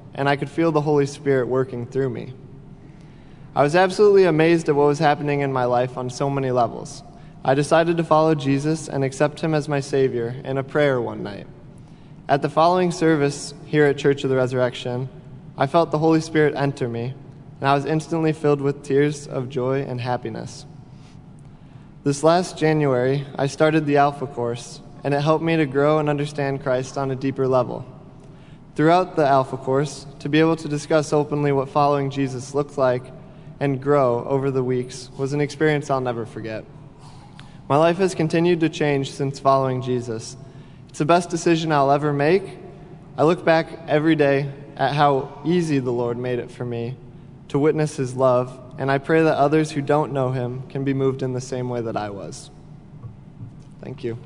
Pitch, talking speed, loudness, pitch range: 140 Hz, 190 wpm, -21 LUFS, 130-155 Hz